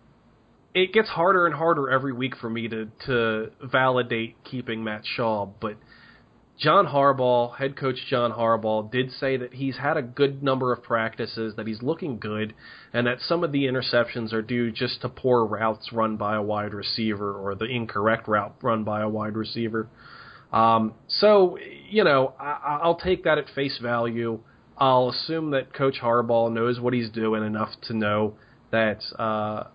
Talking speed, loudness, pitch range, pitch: 175 wpm, -24 LUFS, 110-135 Hz, 120 Hz